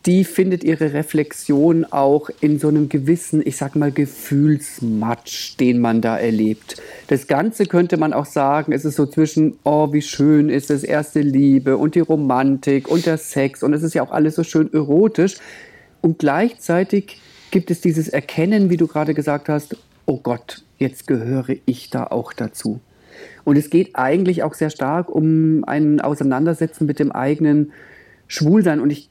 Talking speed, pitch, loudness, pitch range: 175 wpm, 150 Hz, -18 LUFS, 145-165 Hz